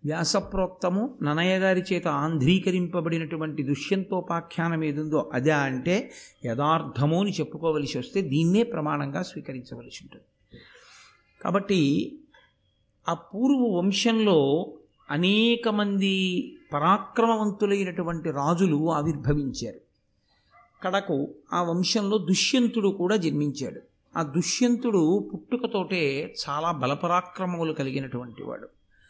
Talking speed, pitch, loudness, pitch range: 80 wpm, 175 Hz, -26 LUFS, 155-195 Hz